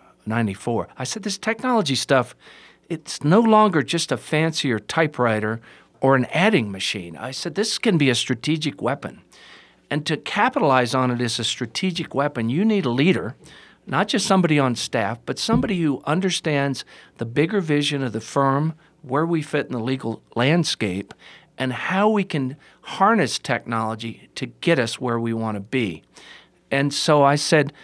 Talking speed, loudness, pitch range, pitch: 170 wpm, -21 LUFS, 120-165 Hz, 140 Hz